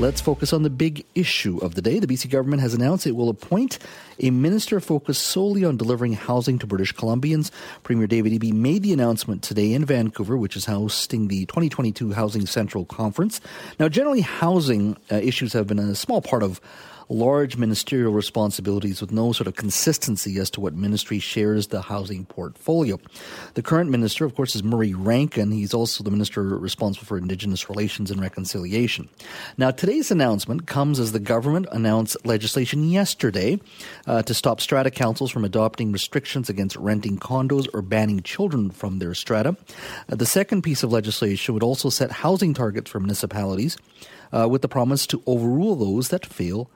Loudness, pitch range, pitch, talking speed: -22 LUFS, 105-140 Hz, 115 Hz, 175 wpm